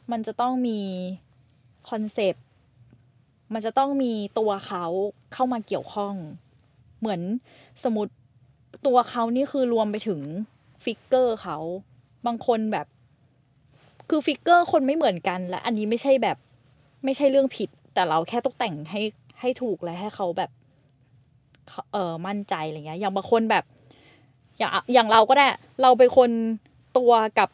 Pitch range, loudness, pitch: 140-240 Hz, -24 LUFS, 205 Hz